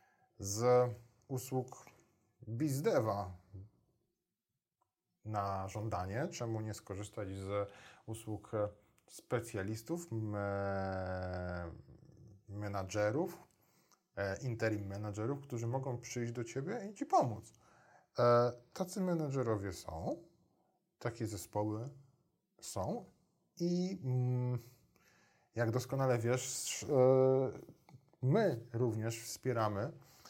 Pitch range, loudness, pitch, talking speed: 105-130 Hz, -37 LUFS, 120 Hz, 70 wpm